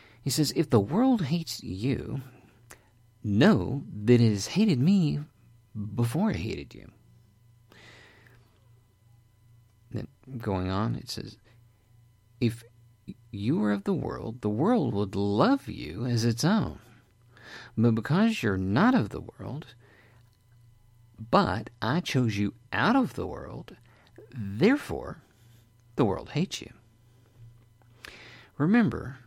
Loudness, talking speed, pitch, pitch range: -27 LUFS, 115 wpm, 115 Hz, 110-125 Hz